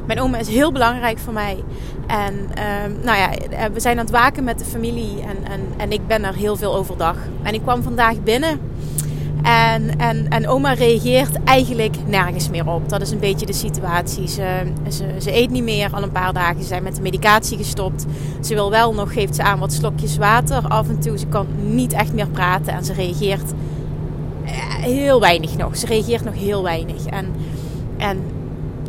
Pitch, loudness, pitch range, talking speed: 165 Hz, -19 LUFS, 145-210 Hz, 200 wpm